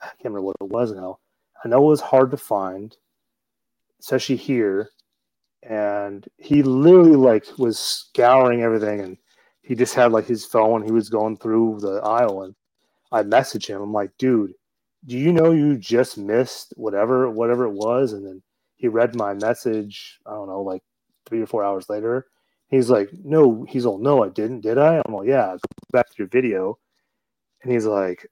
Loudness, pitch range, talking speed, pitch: -20 LUFS, 100-130 Hz, 190 wpm, 115 Hz